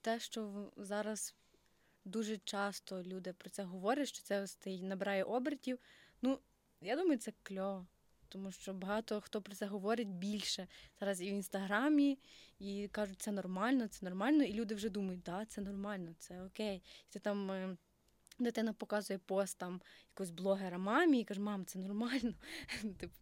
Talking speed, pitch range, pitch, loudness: 160 wpm, 190-220 Hz, 205 Hz, -40 LUFS